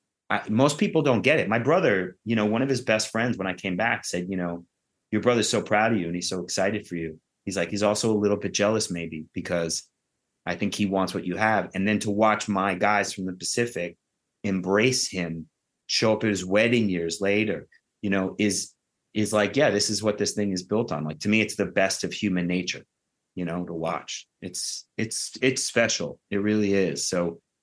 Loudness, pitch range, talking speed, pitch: -25 LUFS, 90-105 Hz, 225 wpm, 100 Hz